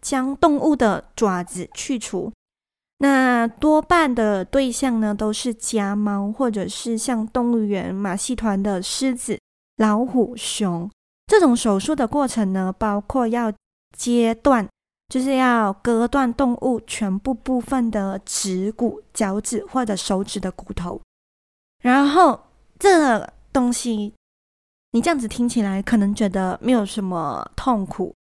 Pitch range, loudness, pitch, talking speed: 205-255 Hz, -21 LUFS, 230 Hz, 200 characters per minute